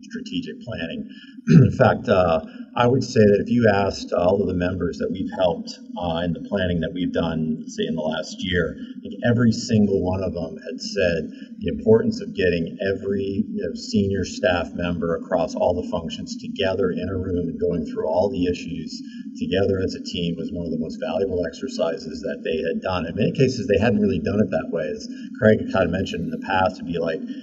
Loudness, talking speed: -22 LUFS, 220 wpm